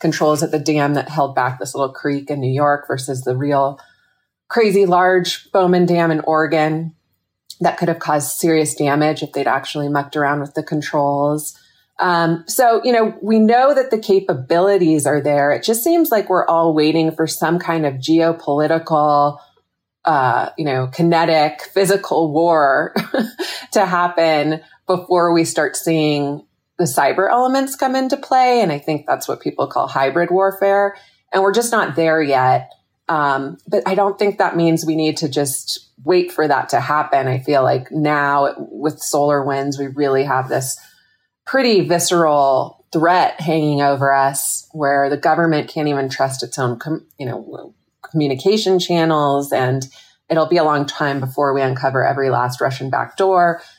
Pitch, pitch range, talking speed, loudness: 155 Hz, 140-180 Hz, 170 wpm, -17 LUFS